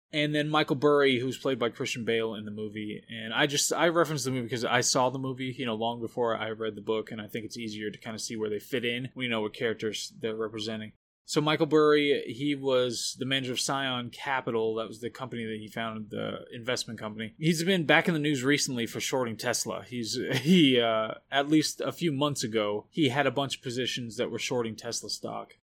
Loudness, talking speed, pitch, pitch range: -29 LUFS, 240 wpm, 125 Hz, 110-140 Hz